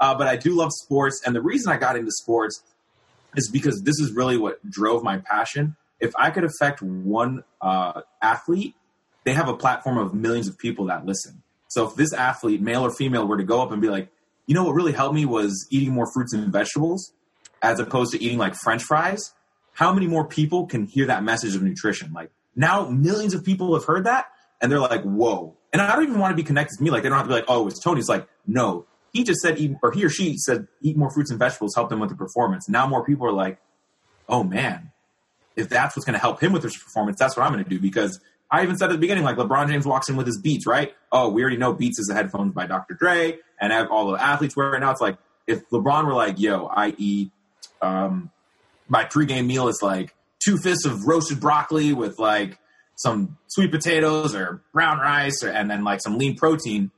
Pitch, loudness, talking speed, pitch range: 135 Hz, -22 LUFS, 240 wpm, 110-155 Hz